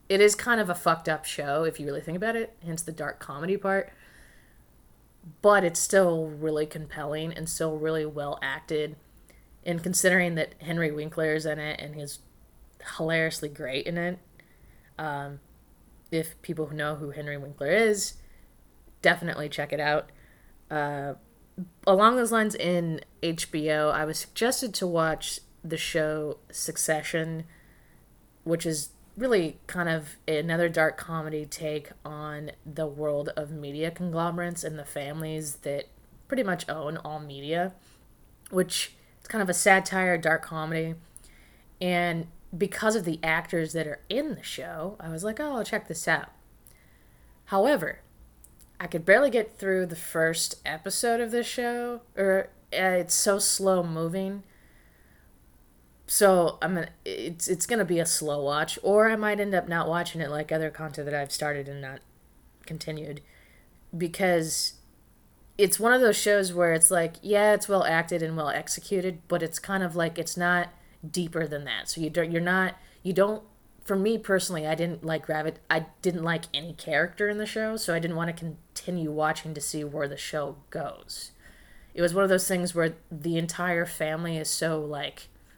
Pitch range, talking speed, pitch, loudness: 150-185 Hz, 165 wpm, 165 Hz, -27 LUFS